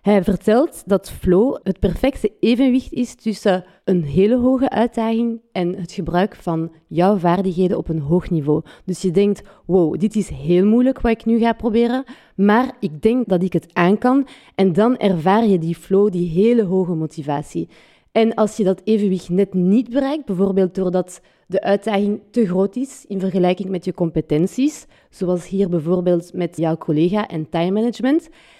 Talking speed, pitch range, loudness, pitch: 175 wpm, 180-225 Hz, -19 LUFS, 195 Hz